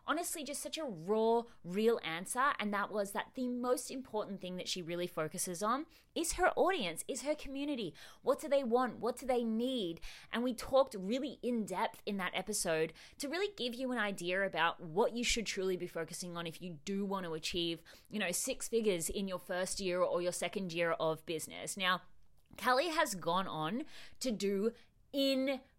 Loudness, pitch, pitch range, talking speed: -36 LUFS, 210 Hz, 180-255 Hz, 200 wpm